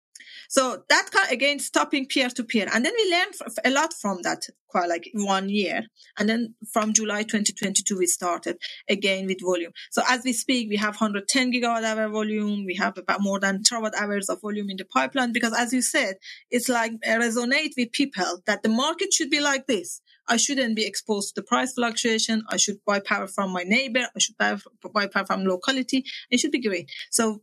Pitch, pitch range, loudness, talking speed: 225 Hz, 200-255 Hz, -24 LUFS, 205 wpm